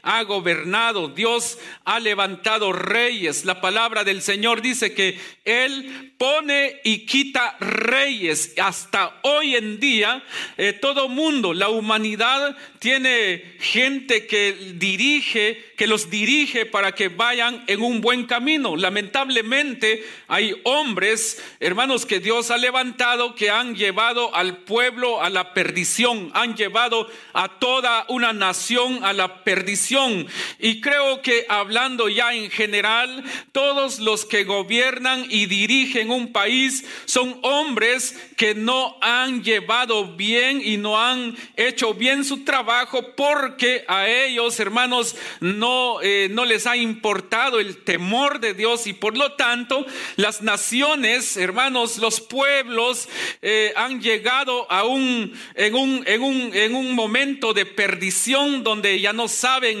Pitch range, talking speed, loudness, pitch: 210-255 Hz, 135 wpm, -19 LUFS, 235 Hz